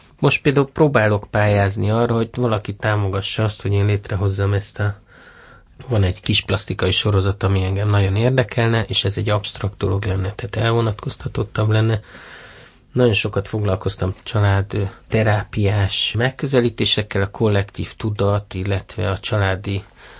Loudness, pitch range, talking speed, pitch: -19 LUFS, 100-115 Hz, 130 wpm, 105 Hz